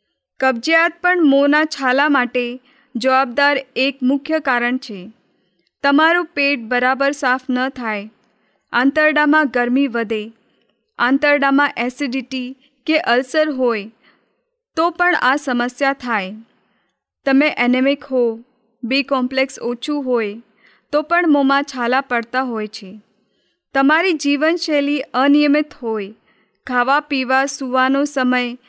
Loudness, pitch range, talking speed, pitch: -17 LUFS, 240-285 Hz, 105 wpm, 265 Hz